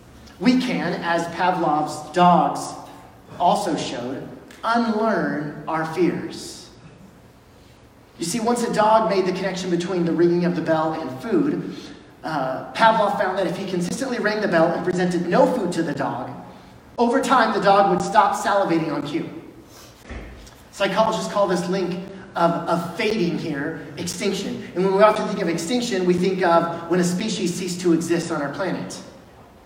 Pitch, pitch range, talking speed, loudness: 180 Hz, 170-205 Hz, 160 wpm, -21 LUFS